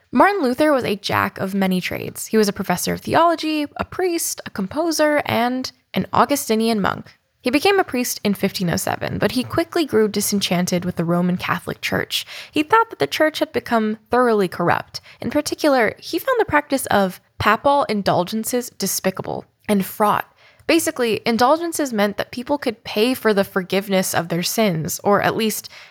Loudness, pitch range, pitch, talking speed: -20 LUFS, 195-295 Hz, 220 Hz, 175 wpm